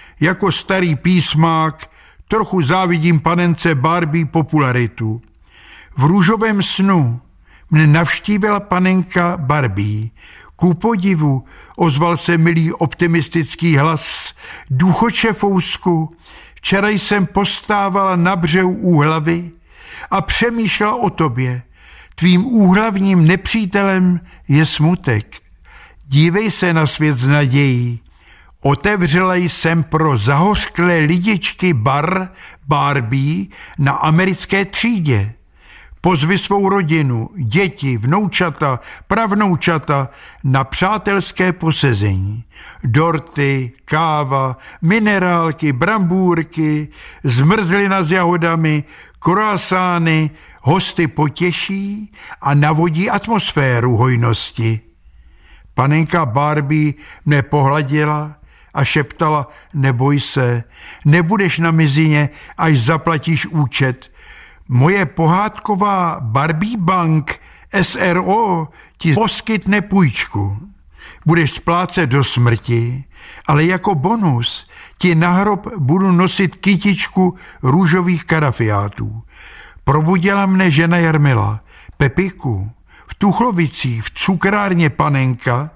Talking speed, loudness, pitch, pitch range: 85 wpm, -15 LUFS, 165 Hz, 140-185 Hz